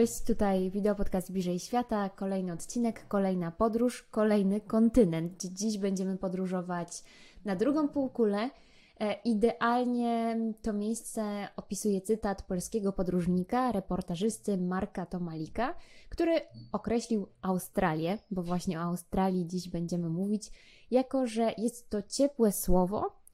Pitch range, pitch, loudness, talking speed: 185-230 Hz, 205 Hz, -31 LUFS, 115 wpm